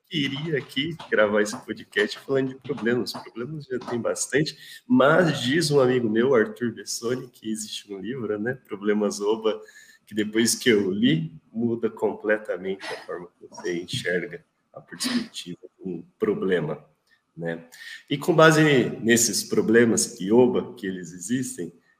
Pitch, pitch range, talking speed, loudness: 125 Hz, 105-155 Hz, 145 wpm, -24 LUFS